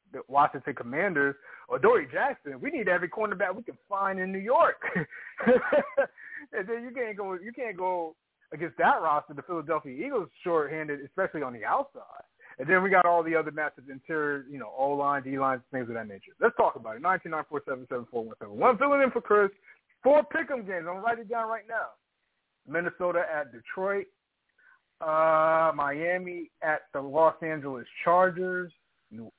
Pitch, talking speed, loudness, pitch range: 175 Hz, 190 wpm, -28 LUFS, 145-215 Hz